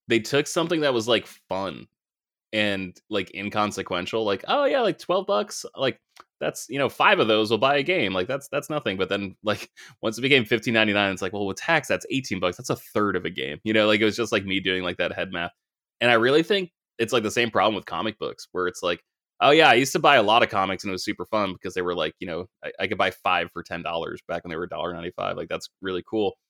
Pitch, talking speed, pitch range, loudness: 110 Hz, 265 wpm, 100-120 Hz, -24 LUFS